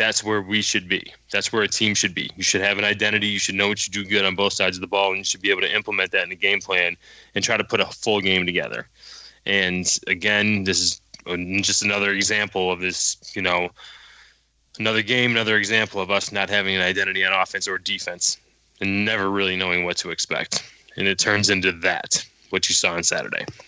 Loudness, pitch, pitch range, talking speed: -21 LUFS, 100 Hz, 95-105 Hz, 230 wpm